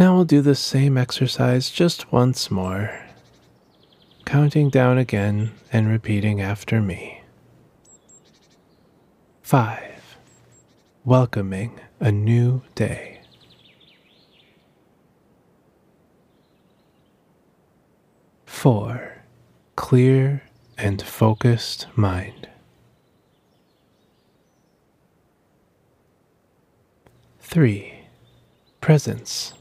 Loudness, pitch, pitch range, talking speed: -20 LUFS, 115 Hz, 100-130 Hz, 55 wpm